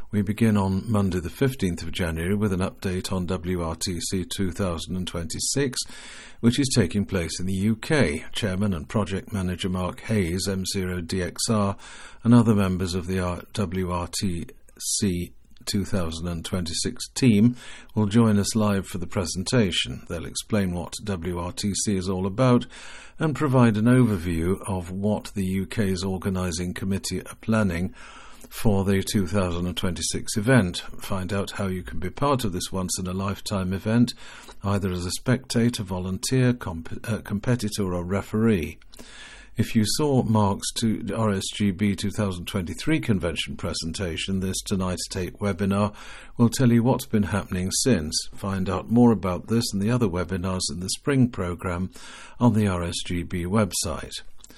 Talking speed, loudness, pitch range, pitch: 135 wpm, -25 LUFS, 90-110 Hz, 100 Hz